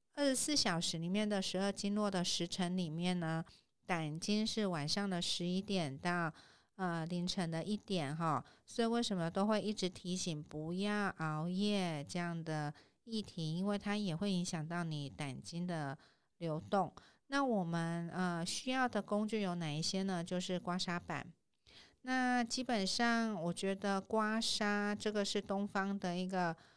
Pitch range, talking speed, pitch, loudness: 170-205 Hz, 240 characters per minute, 185 Hz, -38 LUFS